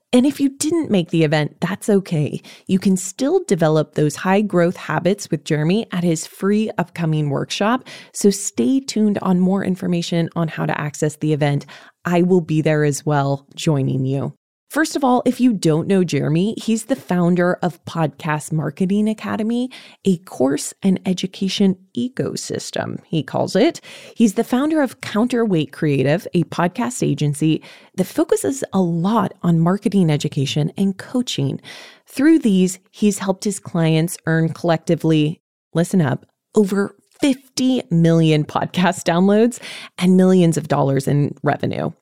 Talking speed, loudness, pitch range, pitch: 150 wpm, -19 LUFS, 155-215 Hz, 180 Hz